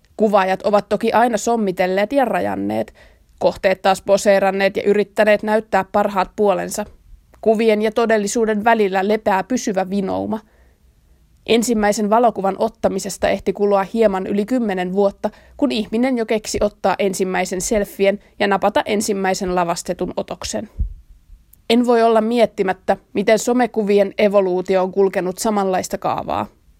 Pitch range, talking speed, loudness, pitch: 190-220 Hz, 120 wpm, -18 LUFS, 200 Hz